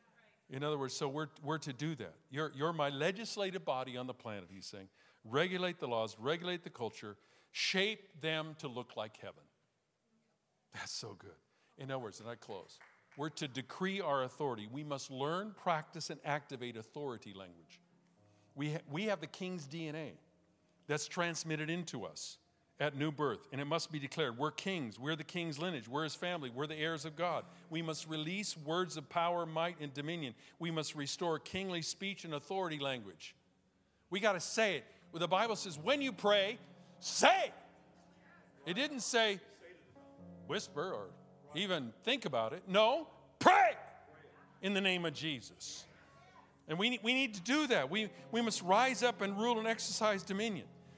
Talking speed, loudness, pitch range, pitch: 175 wpm, -37 LUFS, 145-195 Hz, 165 Hz